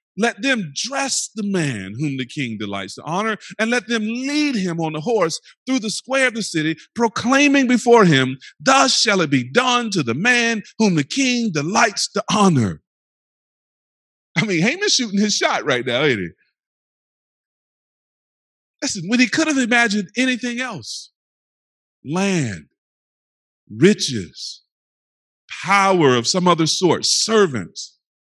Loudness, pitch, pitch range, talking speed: -18 LUFS, 210 Hz, 155-245 Hz, 145 wpm